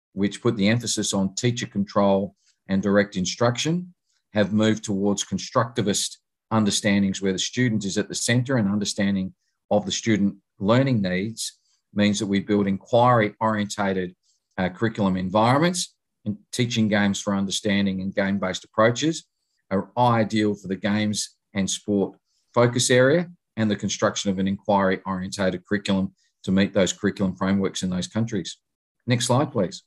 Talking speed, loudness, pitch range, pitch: 150 wpm, -23 LUFS, 95-115 Hz, 105 Hz